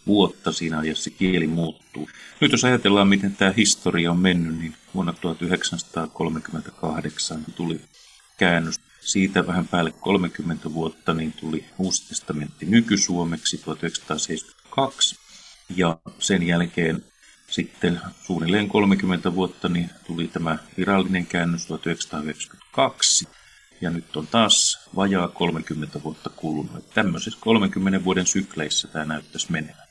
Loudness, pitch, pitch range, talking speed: -23 LUFS, 85 Hz, 80-95 Hz, 115 wpm